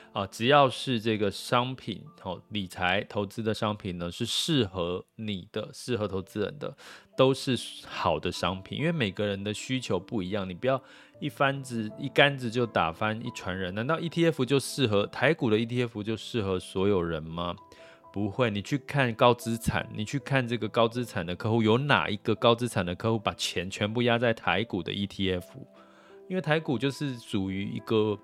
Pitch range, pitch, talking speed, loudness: 100-130 Hz, 110 Hz, 280 characters per minute, -28 LUFS